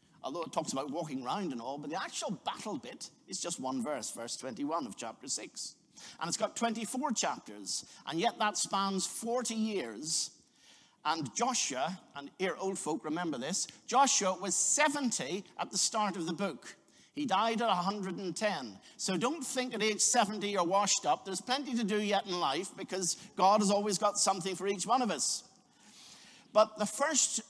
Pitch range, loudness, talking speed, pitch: 190-235 Hz, -33 LUFS, 185 wpm, 210 Hz